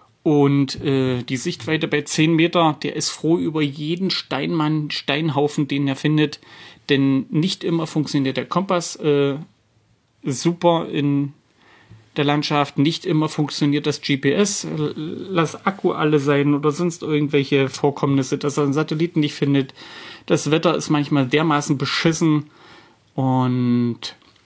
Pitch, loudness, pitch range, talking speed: 150 Hz, -20 LUFS, 140-160 Hz, 135 wpm